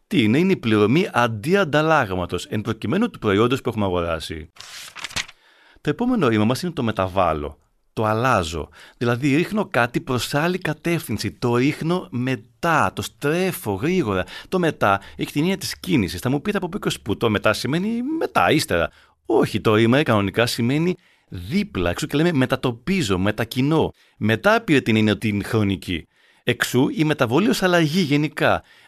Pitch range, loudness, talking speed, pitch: 110-165 Hz, -21 LUFS, 155 wpm, 130 Hz